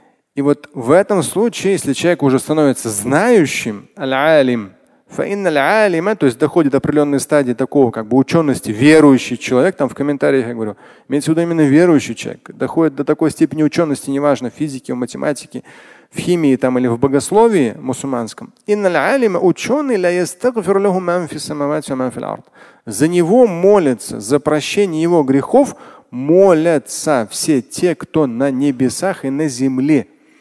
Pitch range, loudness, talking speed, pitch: 135-175 Hz, -15 LUFS, 130 wpm, 150 Hz